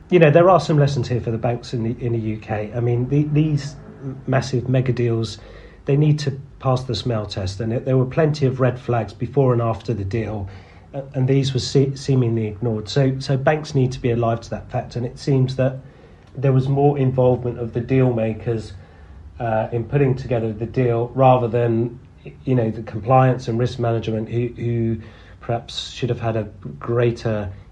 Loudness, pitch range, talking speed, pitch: -20 LUFS, 115-130 Hz, 200 wpm, 120 Hz